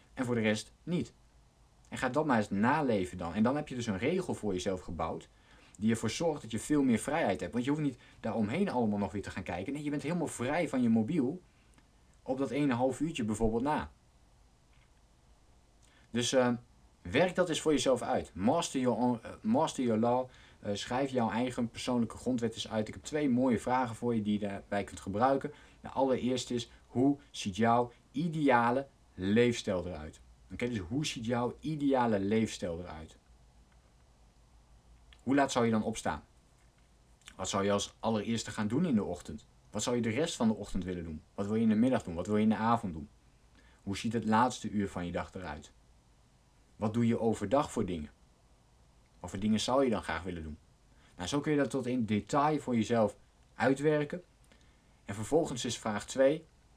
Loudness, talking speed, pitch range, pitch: -32 LUFS, 200 wpm, 95-130 Hz, 110 Hz